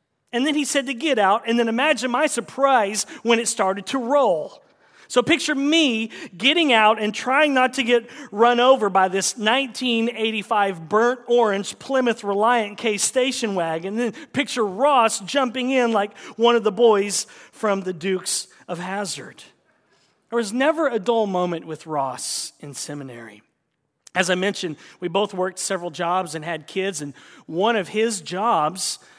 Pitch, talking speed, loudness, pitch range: 220 Hz, 165 wpm, -21 LUFS, 190-250 Hz